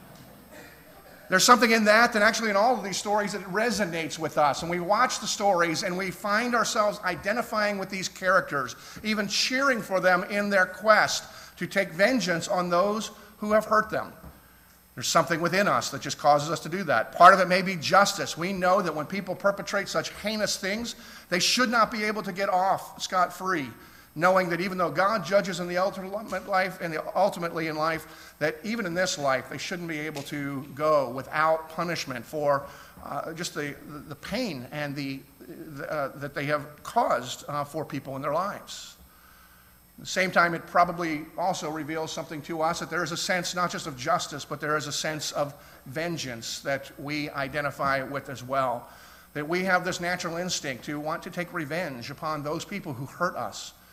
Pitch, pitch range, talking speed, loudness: 175 Hz, 150-195 Hz, 200 wpm, -26 LUFS